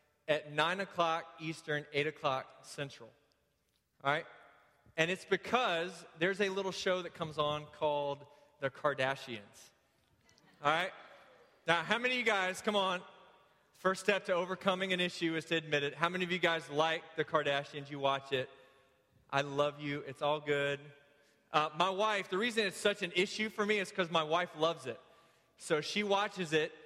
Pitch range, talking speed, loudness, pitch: 145-185 Hz, 180 wpm, -34 LUFS, 165 Hz